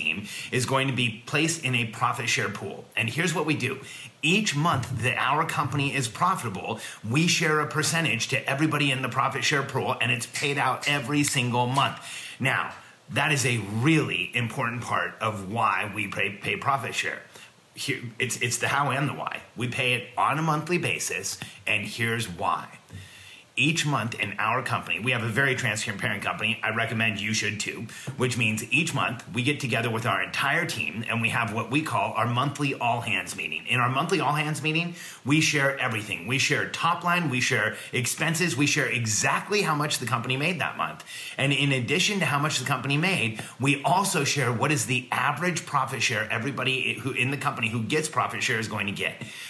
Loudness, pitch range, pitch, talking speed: -25 LUFS, 115-145 Hz, 130 Hz, 200 wpm